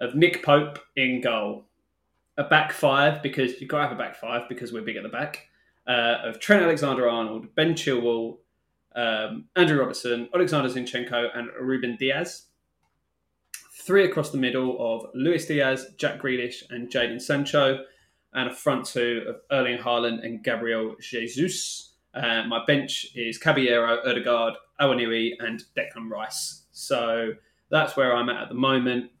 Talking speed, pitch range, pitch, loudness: 160 wpm, 120-140 Hz, 125 Hz, -25 LUFS